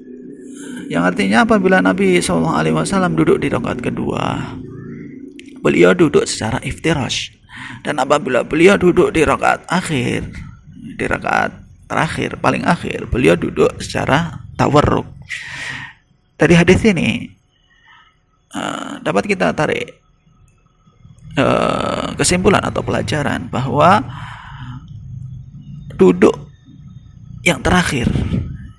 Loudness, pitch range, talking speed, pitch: -16 LUFS, 130-190 Hz, 90 wpm, 145 Hz